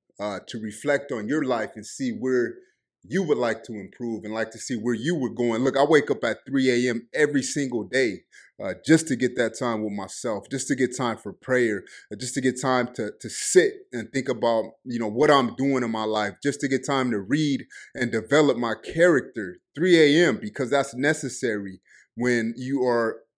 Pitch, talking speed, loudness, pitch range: 125 Hz, 215 wpm, -24 LUFS, 115-140 Hz